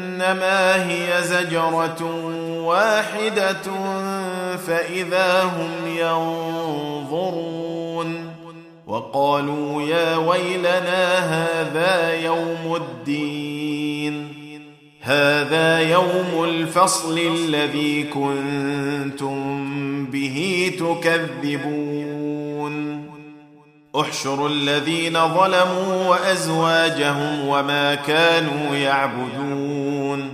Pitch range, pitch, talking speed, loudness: 145-175 Hz, 165 Hz, 55 wpm, -20 LUFS